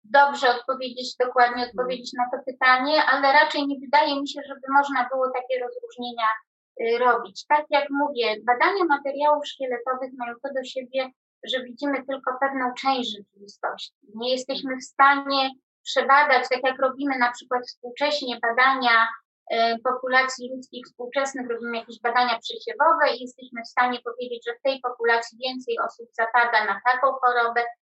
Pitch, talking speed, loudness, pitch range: 255 Hz, 150 wpm, -23 LUFS, 245-275 Hz